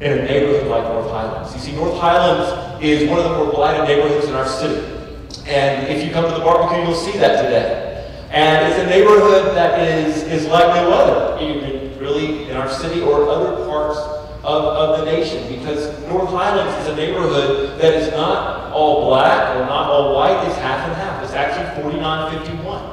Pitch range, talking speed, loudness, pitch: 145-170 Hz, 195 wpm, -16 LUFS, 150 Hz